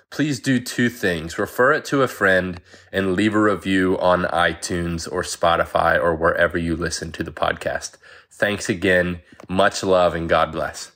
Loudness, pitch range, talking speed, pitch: -20 LUFS, 85-105 Hz, 170 wpm, 90 Hz